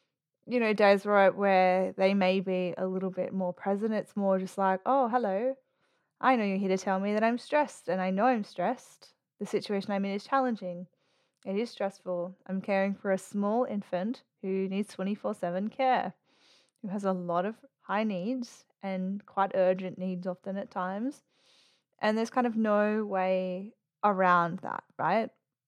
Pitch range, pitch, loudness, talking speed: 185-220 Hz, 195 Hz, -30 LUFS, 180 wpm